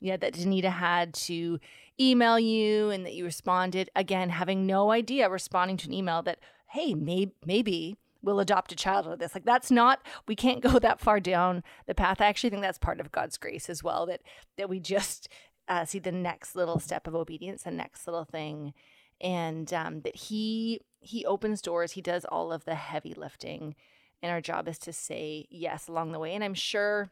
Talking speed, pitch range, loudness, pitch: 210 wpm, 170-210 Hz, -29 LUFS, 185 Hz